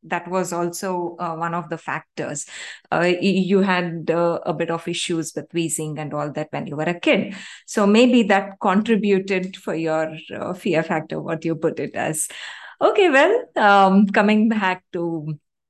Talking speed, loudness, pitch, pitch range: 175 wpm, -20 LUFS, 175 Hz, 165-195 Hz